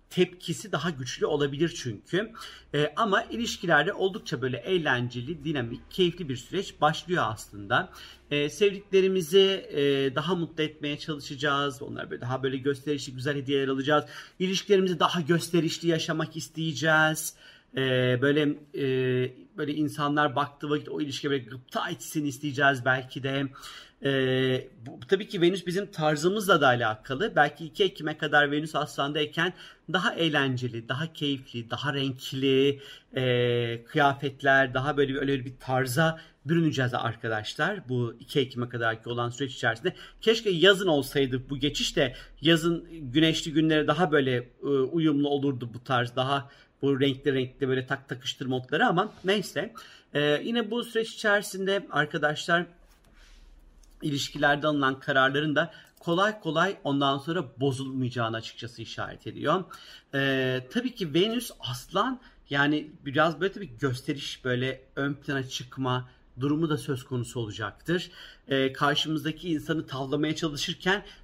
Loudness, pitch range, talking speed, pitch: -27 LUFS, 135-165 Hz, 135 wpm, 145 Hz